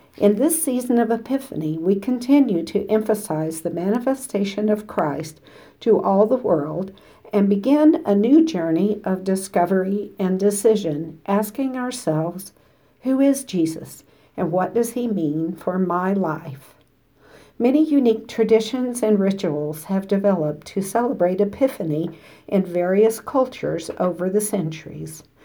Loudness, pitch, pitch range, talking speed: -21 LUFS, 200 Hz, 170-235 Hz, 130 wpm